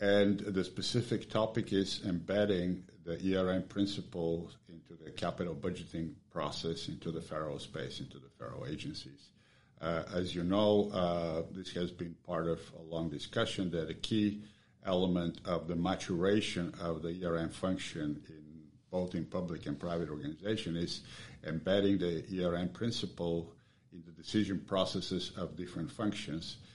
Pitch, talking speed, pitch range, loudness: 90 Hz, 145 wpm, 85-100 Hz, -36 LUFS